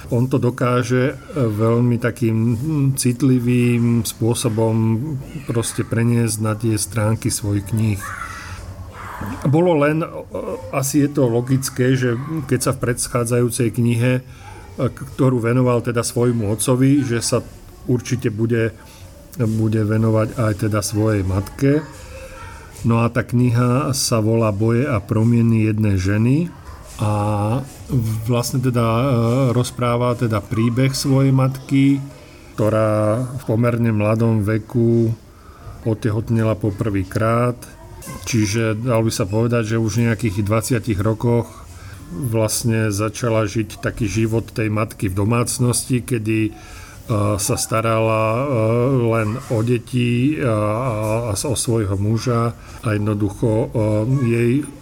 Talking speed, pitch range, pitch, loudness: 110 wpm, 110-125 Hz, 115 Hz, -19 LUFS